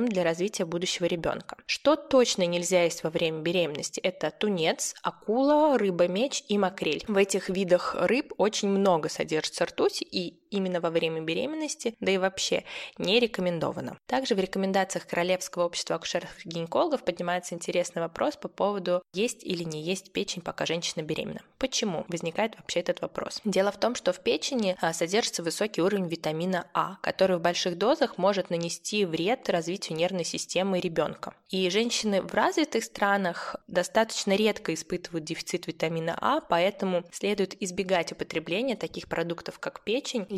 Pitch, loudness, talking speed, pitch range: 185 Hz, -28 LUFS, 150 wpm, 175-210 Hz